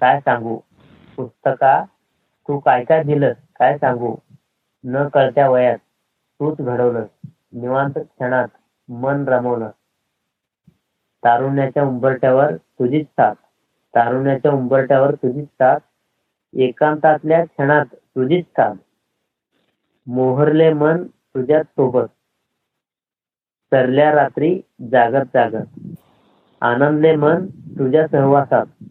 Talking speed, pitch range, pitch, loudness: 80 wpm, 125-150 Hz, 135 Hz, -17 LUFS